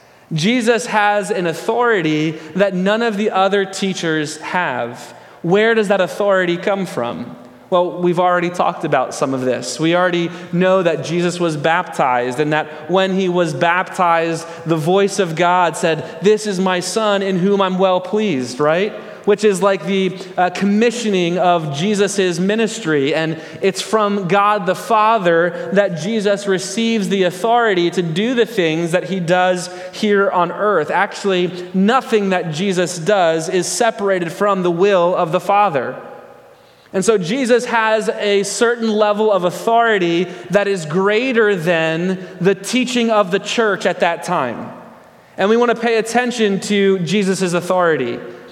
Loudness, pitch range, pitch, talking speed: -16 LUFS, 175-210 Hz, 190 Hz, 155 wpm